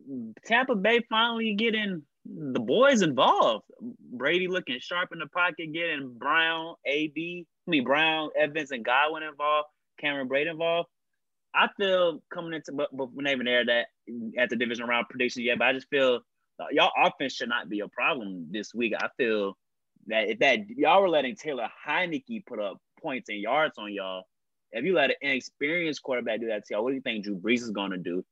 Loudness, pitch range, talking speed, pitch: -27 LUFS, 125-175 Hz, 200 wpm, 150 Hz